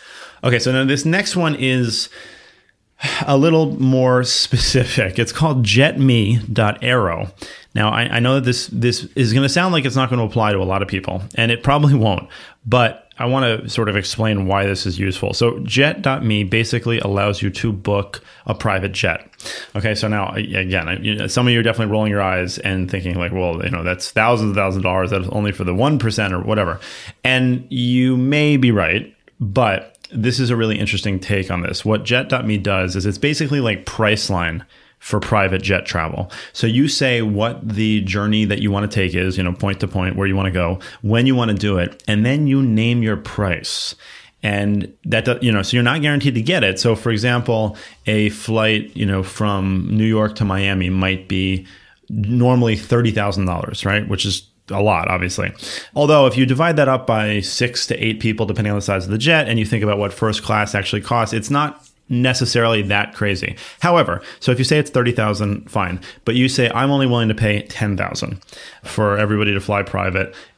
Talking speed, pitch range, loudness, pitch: 205 wpm, 100-125 Hz, -18 LUFS, 110 Hz